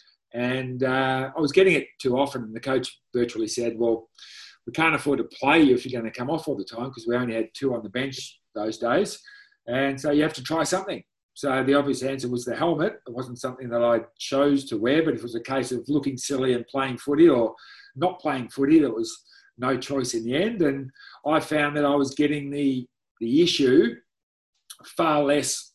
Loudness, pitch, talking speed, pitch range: -24 LUFS, 135 Hz, 225 wpm, 125-150 Hz